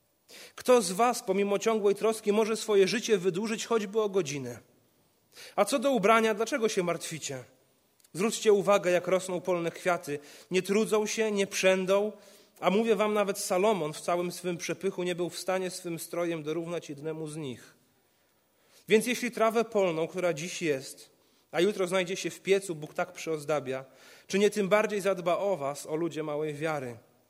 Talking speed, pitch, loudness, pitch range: 170 wpm, 185 Hz, -29 LUFS, 165-210 Hz